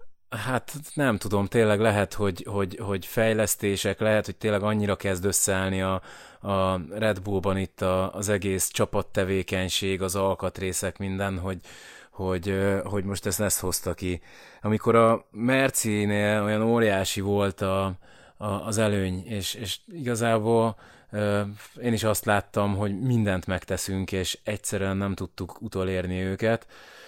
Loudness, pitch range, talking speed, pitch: -26 LUFS, 95-110 Hz, 135 wpm, 100 Hz